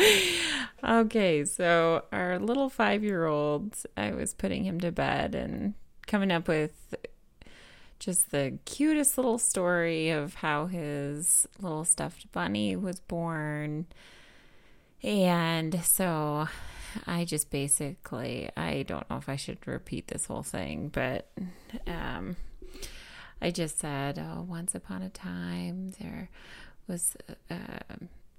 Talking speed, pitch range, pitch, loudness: 120 wpm, 150-205 Hz, 170 Hz, -30 LUFS